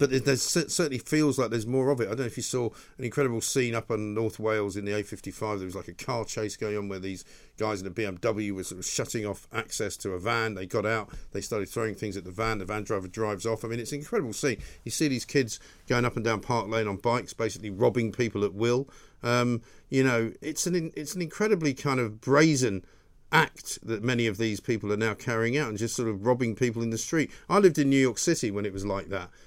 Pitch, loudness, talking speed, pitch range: 115 Hz, -28 LUFS, 260 wpm, 105-130 Hz